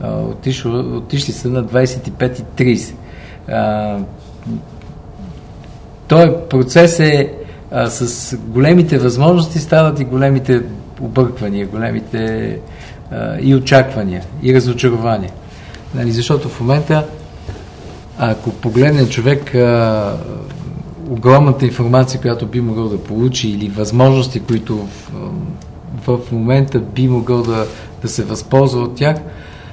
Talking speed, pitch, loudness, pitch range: 110 wpm, 125 Hz, -14 LUFS, 115-135 Hz